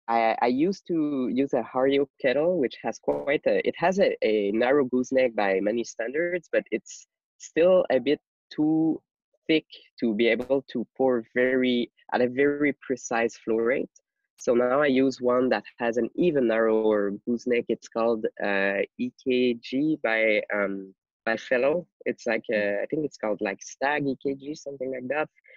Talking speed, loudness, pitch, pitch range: 170 wpm, -26 LUFS, 125 Hz, 115-145 Hz